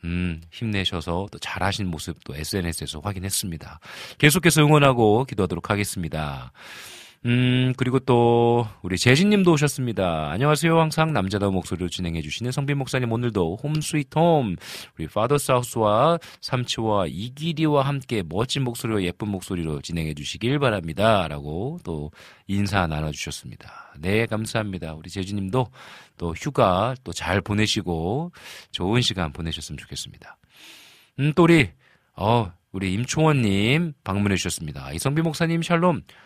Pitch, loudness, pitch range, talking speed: 105 Hz, -23 LUFS, 90-135 Hz, 335 characters per minute